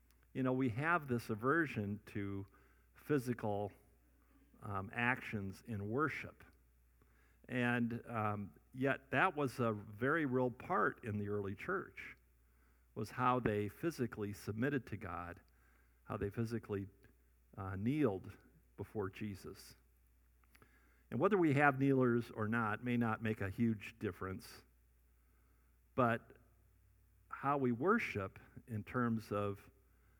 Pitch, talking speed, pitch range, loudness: 105 Hz, 115 wpm, 85-120 Hz, -39 LUFS